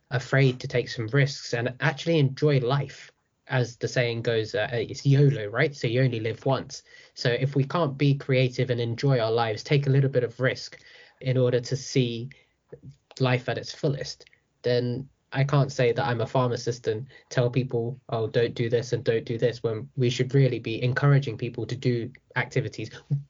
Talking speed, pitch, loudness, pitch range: 195 wpm, 125 Hz, -26 LUFS, 120-140 Hz